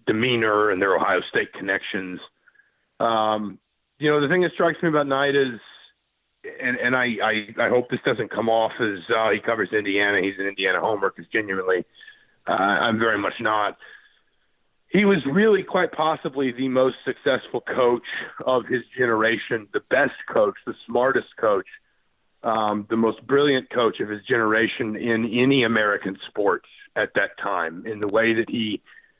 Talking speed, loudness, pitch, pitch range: 165 wpm, -22 LUFS, 130 Hz, 110-170 Hz